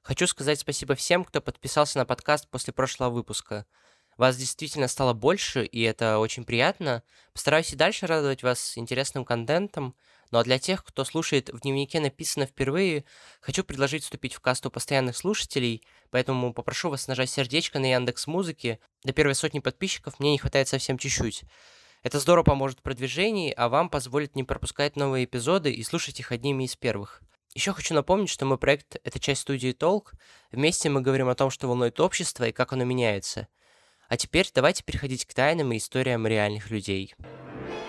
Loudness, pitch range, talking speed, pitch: -26 LUFS, 125-150 Hz, 175 wpm, 135 Hz